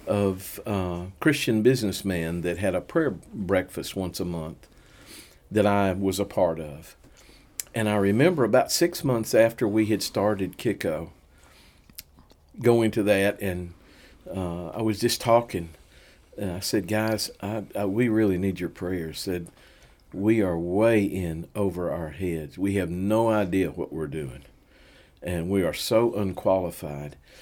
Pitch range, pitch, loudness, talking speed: 85-110 Hz, 95 Hz, -25 LUFS, 155 wpm